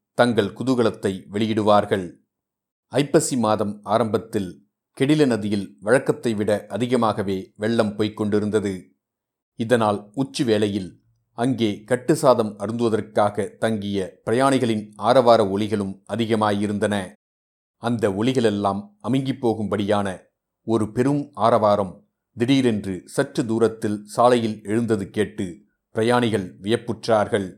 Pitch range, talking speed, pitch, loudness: 105-120 Hz, 85 wpm, 110 Hz, -22 LUFS